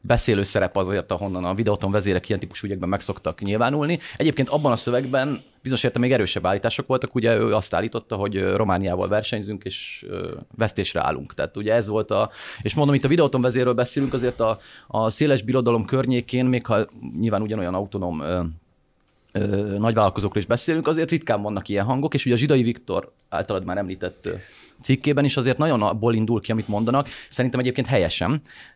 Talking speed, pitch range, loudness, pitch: 175 wpm, 100-130 Hz, -23 LUFS, 115 Hz